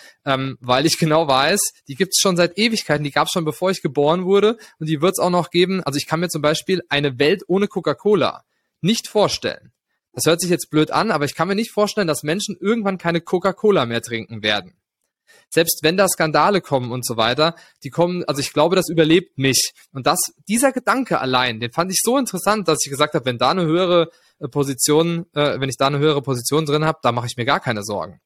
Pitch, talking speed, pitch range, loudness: 160 Hz, 230 wpm, 145-185 Hz, -19 LUFS